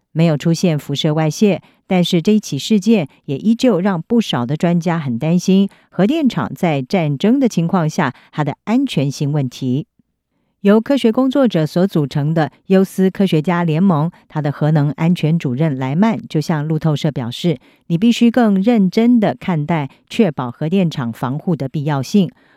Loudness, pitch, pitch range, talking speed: -16 LUFS, 170 Hz, 150-205 Hz, 260 characters per minute